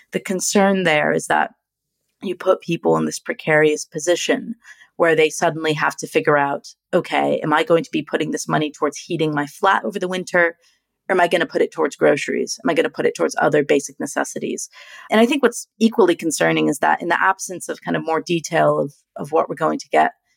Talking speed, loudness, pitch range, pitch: 225 wpm, -19 LUFS, 155-195 Hz, 170 Hz